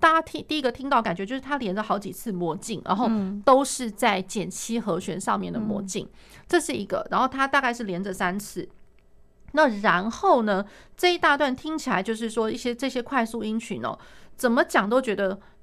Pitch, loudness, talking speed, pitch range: 230 Hz, -25 LUFS, 300 characters per minute, 200-270 Hz